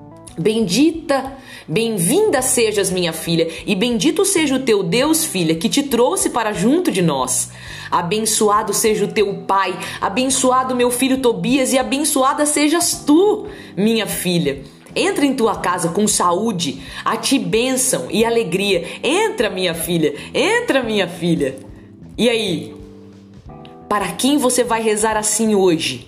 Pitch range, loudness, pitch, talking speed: 175-265 Hz, -17 LUFS, 220 Hz, 140 wpm